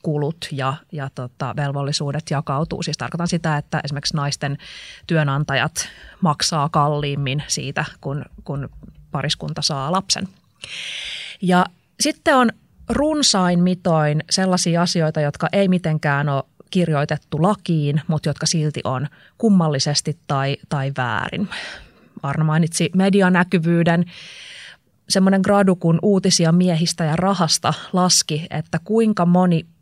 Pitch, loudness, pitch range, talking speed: 160 Hz, -19 LUFS, 145-180 Hz, 115 wpm